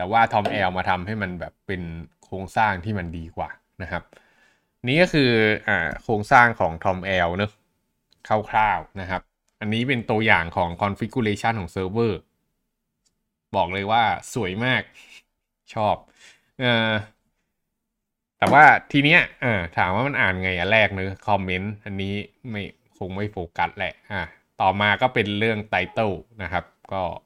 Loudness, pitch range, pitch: -22 LUFS, 95-110 Hz, 105 Hz